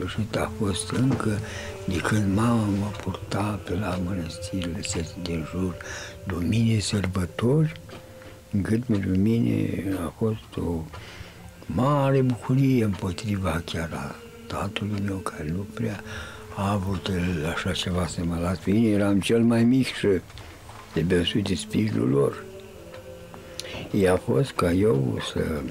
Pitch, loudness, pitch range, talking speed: 100 Hz, -25 LUFS, 90-110 Hz, 130 wpm